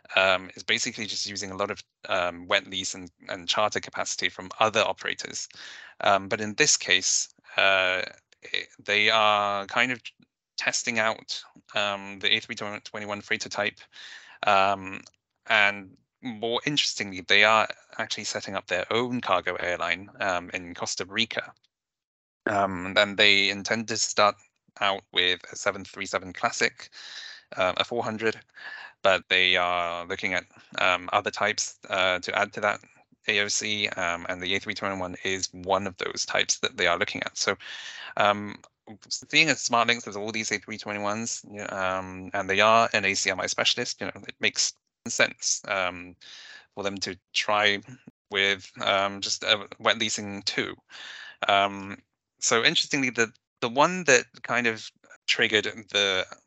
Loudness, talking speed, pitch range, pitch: -25 LUFS, 150 wpm, 95-110 Hz, 100 Hz